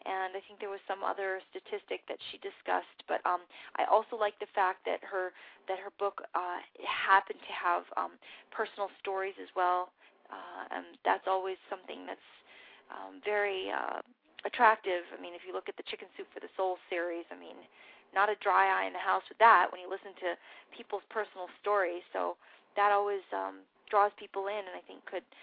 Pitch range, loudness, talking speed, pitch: 185-210 Hz, -33 LUFS, 200 wpm, 195 Hz